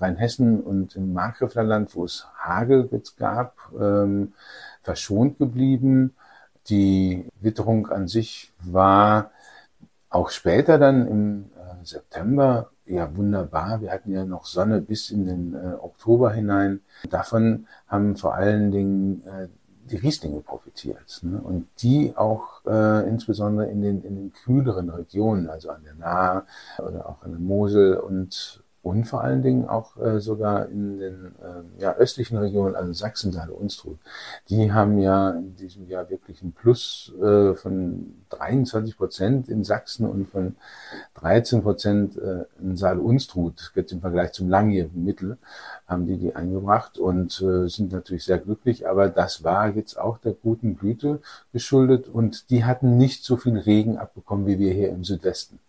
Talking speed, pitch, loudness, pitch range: 155 wpm, 100 Hz, -23 LUFS, 95-115 Hz